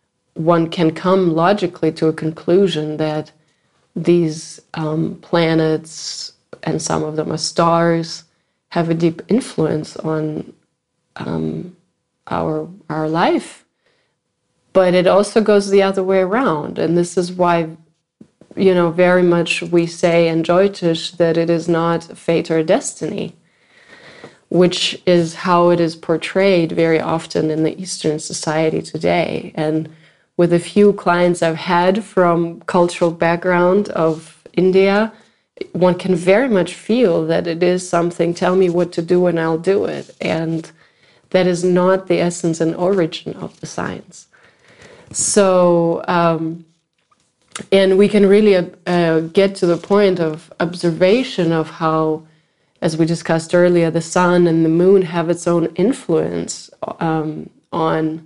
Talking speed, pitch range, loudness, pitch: 140 wpm, 165-185 Hz, -16 LUFS, 170 Hz